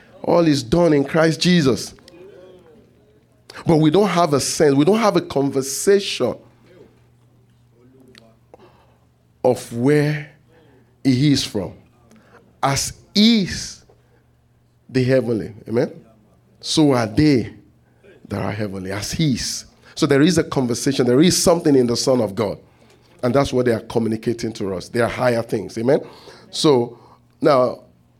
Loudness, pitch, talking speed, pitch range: -18 LUFS, 125 Hz, 135 wpm, 115-150 Hz